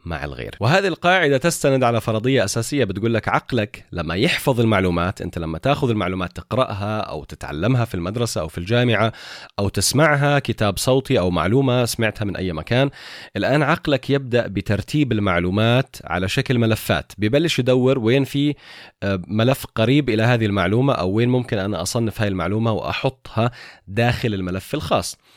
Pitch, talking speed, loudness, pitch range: 115 Hz, 150 wpm, -20 LUFS, 100-130 Hz